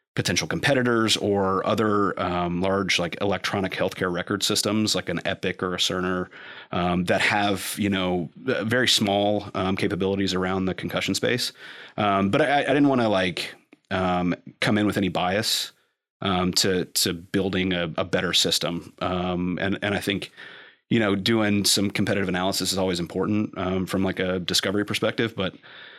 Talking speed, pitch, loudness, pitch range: 170 wpm, 95 Hz, -24 LUFS, 90-105 Hz